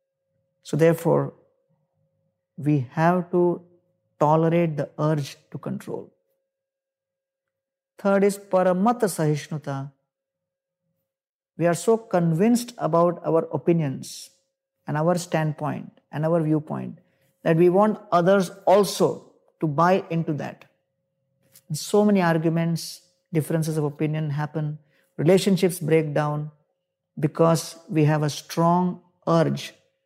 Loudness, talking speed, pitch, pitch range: -23 LUFS, 105 wpm, 170 Hz, 155-190 Hz